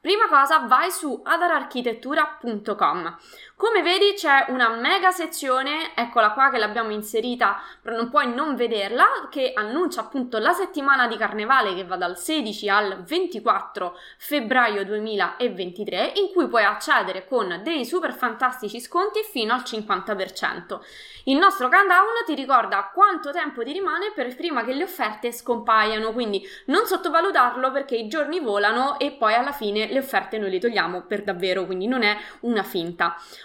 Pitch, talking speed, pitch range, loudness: 250 Hz, 155 wpm, 215-315 Hz, -22 LUFS